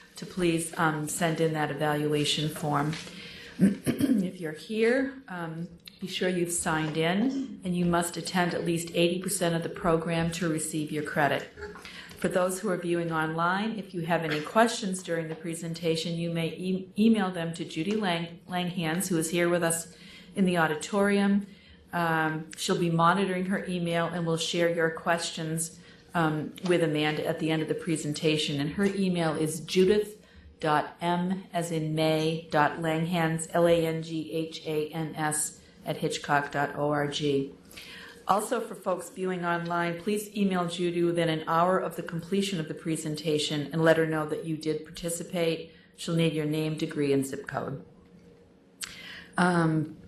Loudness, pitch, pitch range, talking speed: -28 LUFS, 165 Hz, 160-180 Hz, 160 wpm